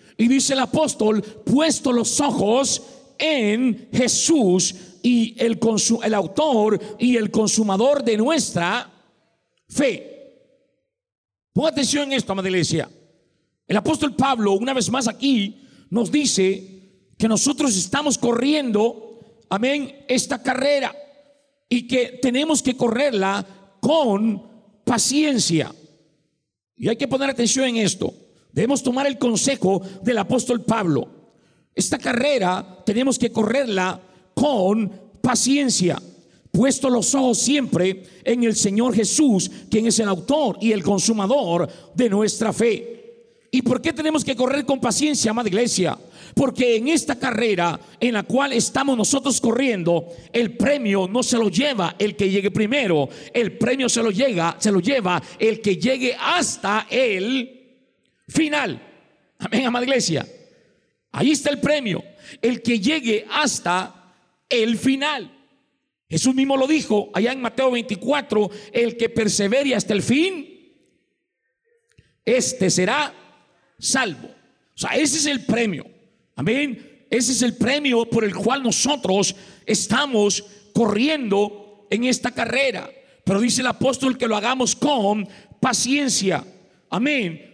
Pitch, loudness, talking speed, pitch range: 235 Hz, -20 LUFS, 130 wpm, 205-270 Hz